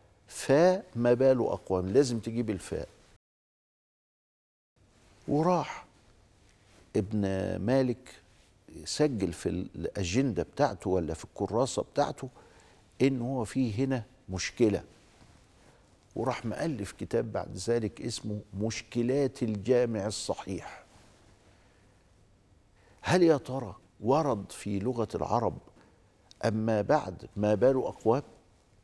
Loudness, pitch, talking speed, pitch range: -30 LUFS, 105 Hz, 90 wpm, 100-120 Hz